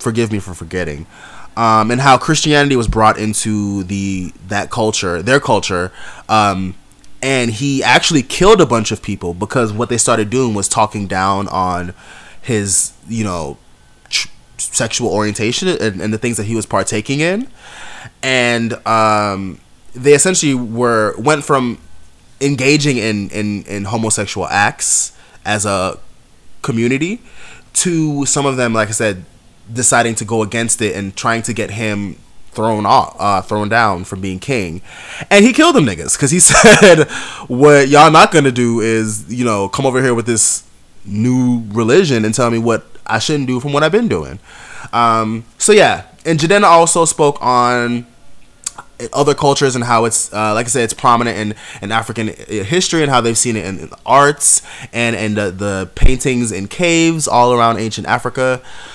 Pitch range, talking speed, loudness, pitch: 105-135 Hz, 170 wpm, -13 LUFS, 115 Hz